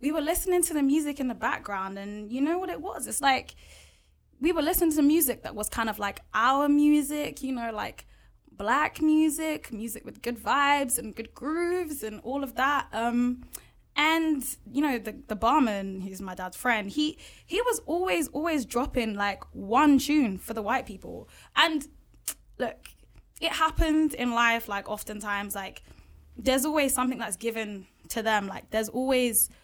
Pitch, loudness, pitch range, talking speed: 260 Hz, -27 LUFS, 220-300 Hz, 180 wpm